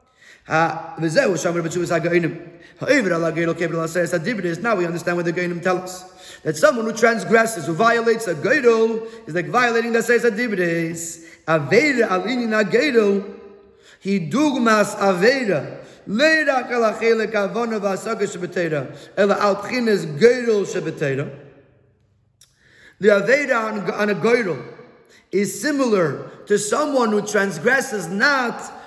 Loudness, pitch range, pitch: -19 LUFS, 170-230 Hz, 200 Hz